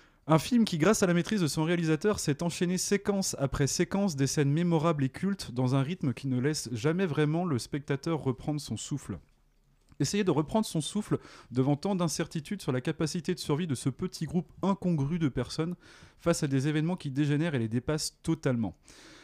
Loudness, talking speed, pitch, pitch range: -30 LUFS, 195 wpm, 155 Hz, 140-180 Hz